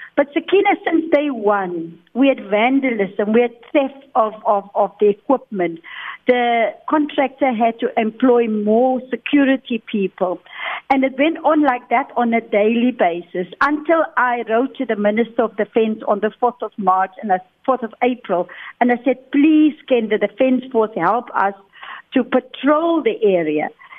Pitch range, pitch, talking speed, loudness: 210-270 Hz, 240 Hz, 165 wpm, -18 LUFS